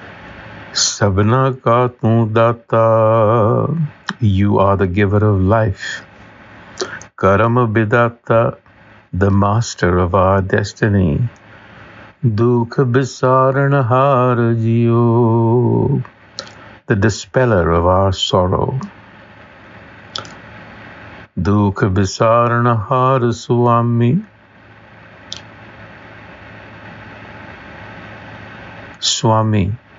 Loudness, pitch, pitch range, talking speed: -15 LUFS, 110 Hz, 100-120 Hz, 60 wpm